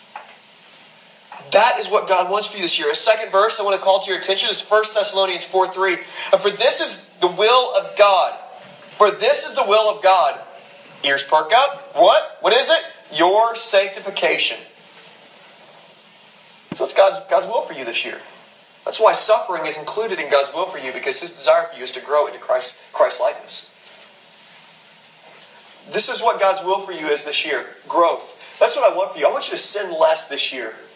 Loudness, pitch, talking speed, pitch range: -16 LUFS, 195 Hz, 200 wpm, 185-230 Hz